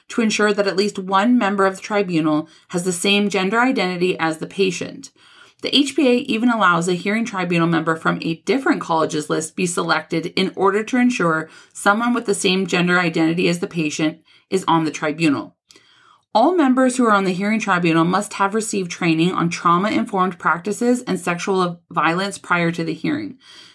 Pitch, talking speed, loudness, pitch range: 190 Hz, 180 wpm, -19 LUFS, 165-205 Hz